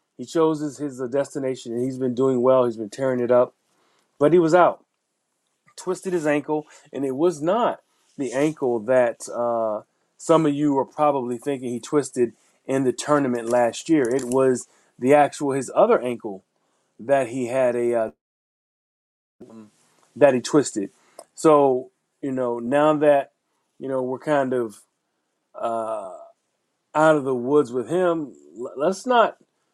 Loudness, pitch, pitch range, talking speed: -22 LUFS, 135 Hz, 125-150 Hz, 155 wpm